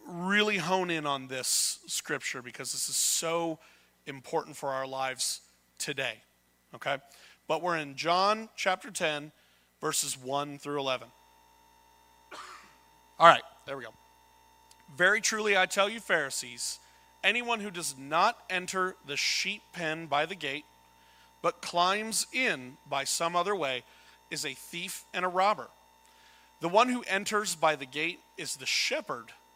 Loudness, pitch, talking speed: -30 LUFS, 145 Hz, 145 wpm